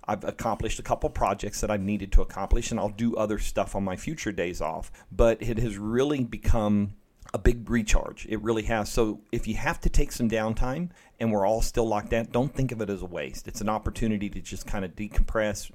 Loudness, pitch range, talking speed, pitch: -29 LUFS, 100-115 Hz, 230 wpm, 110 Hz